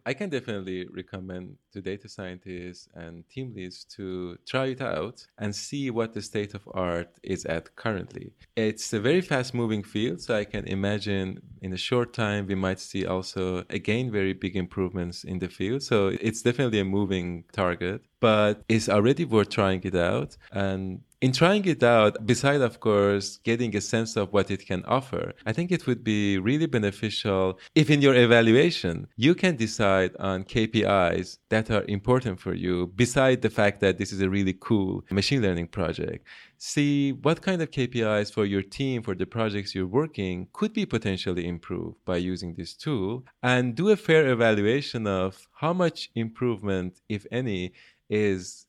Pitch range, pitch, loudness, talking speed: 95-125 Hz, 105 Hz, -26 LUFS, 175 wpm